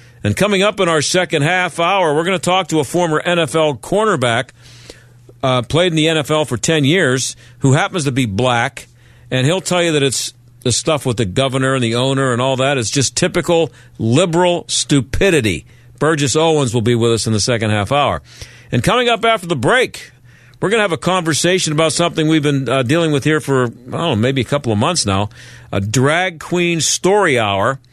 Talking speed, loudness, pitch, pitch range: 210 wpm, -15 LUFS, 140 Hz, 120-165 Hz